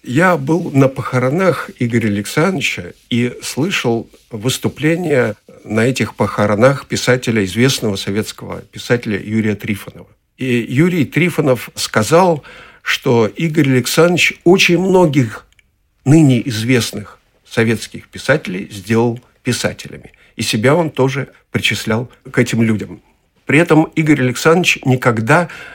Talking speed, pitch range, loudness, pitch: 105 wpm, 110-150 Hz, -15 LUFS, 125 Hz